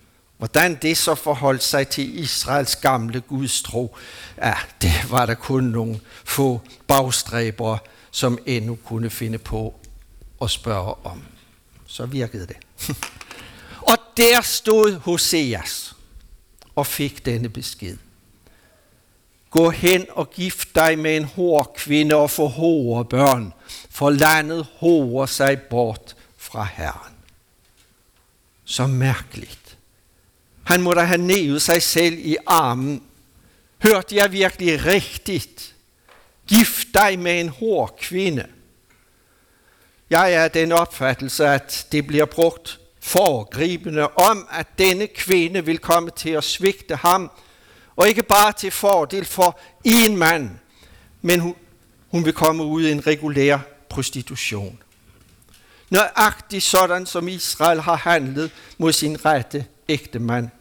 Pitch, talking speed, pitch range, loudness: 150 Hz, 125 wpm, 120-170 Hz, -19 LUFS